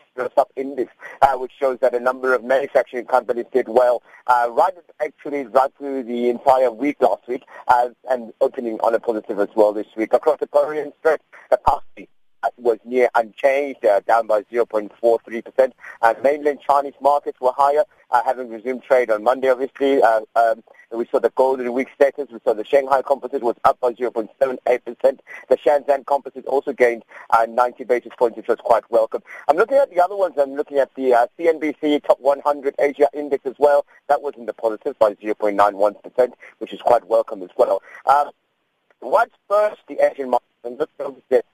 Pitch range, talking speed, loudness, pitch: 115-140 Hz, 185 wpm, -20 LUFS, 130 Hz